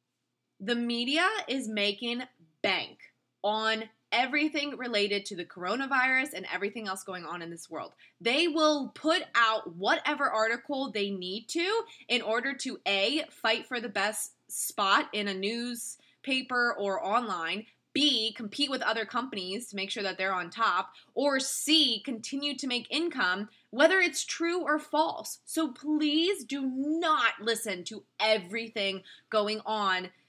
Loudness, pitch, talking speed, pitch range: -29 LUFS, 235 Hz, 145 wpm, 205-285 Hz